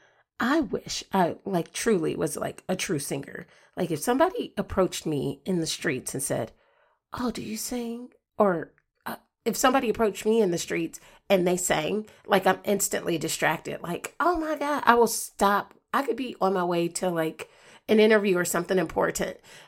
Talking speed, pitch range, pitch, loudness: 185 wpm, 180-235 Hz, 205 Hz, -26 LUFS